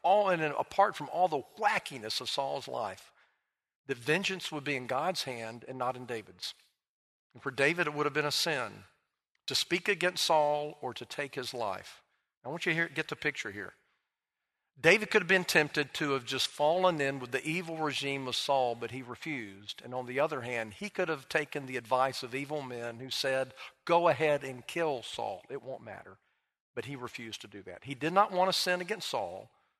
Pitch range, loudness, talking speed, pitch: 130-170 Hz, -32 LUFS, 210 wpm, 145 Hz